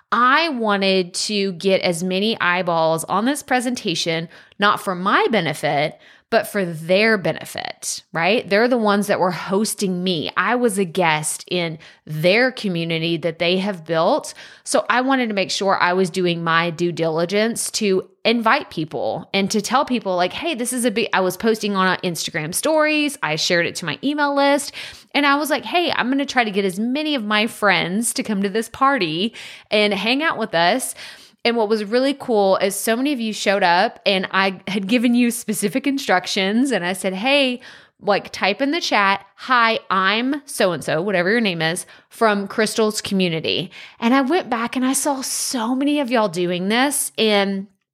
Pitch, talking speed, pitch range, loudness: 210 Hz, 195 wpm, 185-250 Hz, -19 LUFS